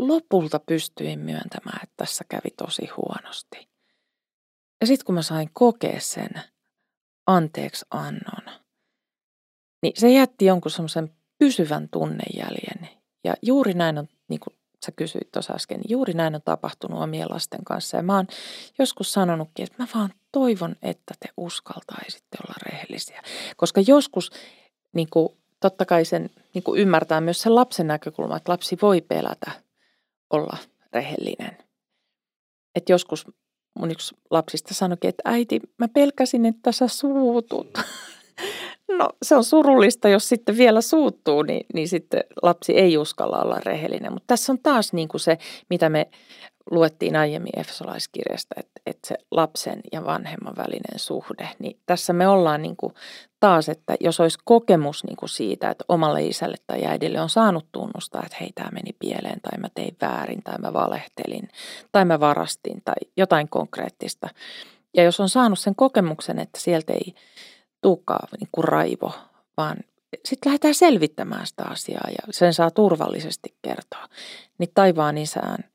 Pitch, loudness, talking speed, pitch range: 185 Hz, -22 LUFS, 150 wpm, 160-235 Hz